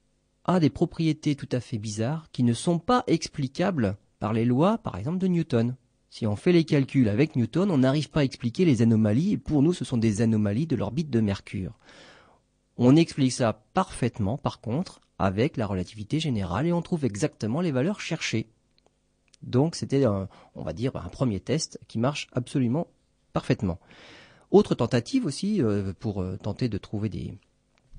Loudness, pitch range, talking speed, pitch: -26 LUFS, 110-155 Hz, 175 wpm, 130 Hz